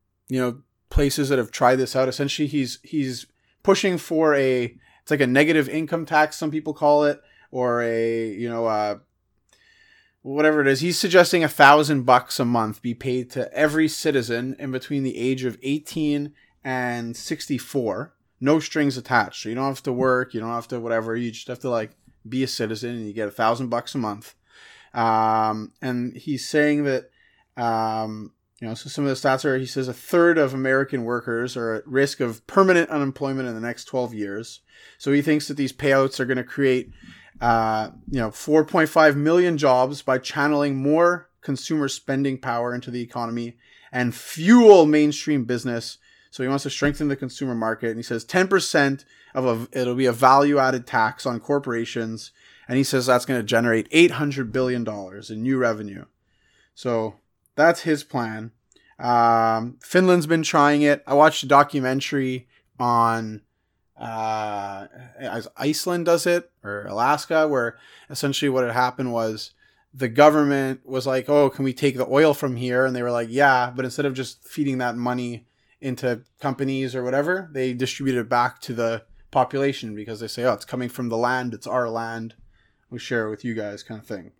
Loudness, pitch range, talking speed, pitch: -22 LUFS, 115-145 Hz, 185 wpm, 130 Hz